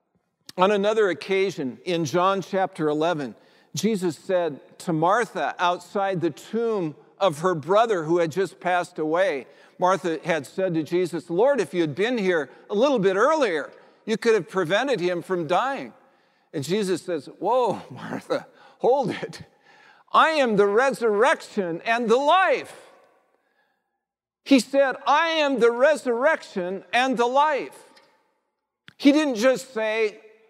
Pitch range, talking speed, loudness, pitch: 175-250 Hz, 140 wpm, -23 LUFS, 195 Hz